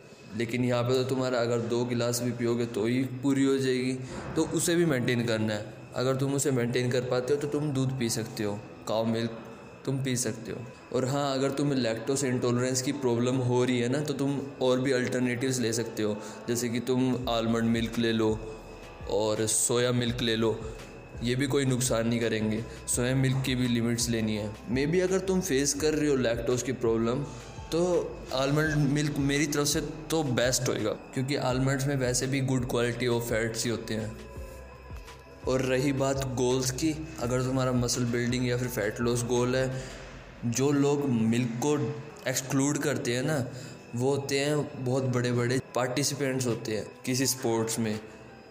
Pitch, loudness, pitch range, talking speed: 125 Hz, -28 LUFS, 115-135 Hz, 190 wpm